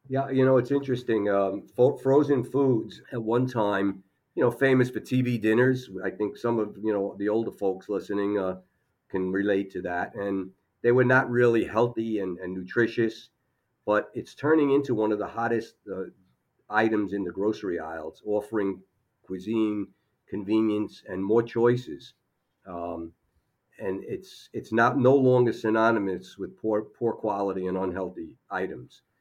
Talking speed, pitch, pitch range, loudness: 160 wpm, 110 Hz, 100-120 Hz, -26 LUFS